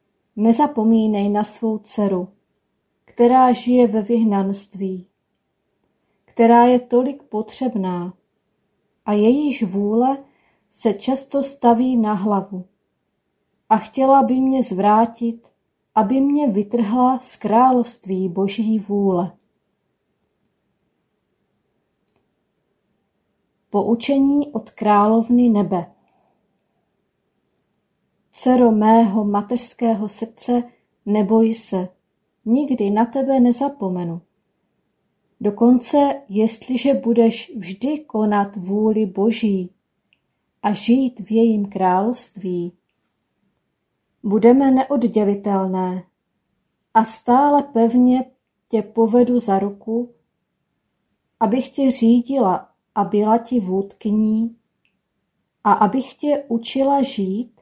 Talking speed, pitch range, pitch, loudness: 80 wpm, 205-245 Hz, 220 Hz, -18 LUFS